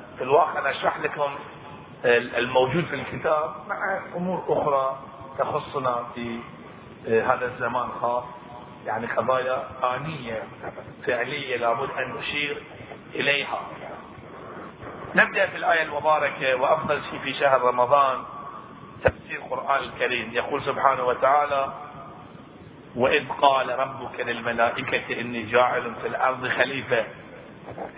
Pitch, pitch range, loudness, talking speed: 130 Hz, 120-145 Hz, -24 LUFS, 105 wpm